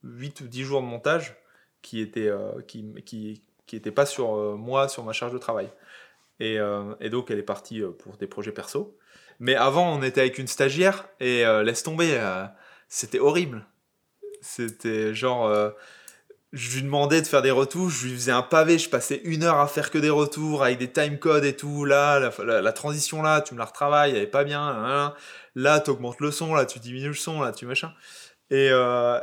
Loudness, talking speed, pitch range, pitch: -24 LUFS, 225 wpm, 120-150 Hz, 135 Hz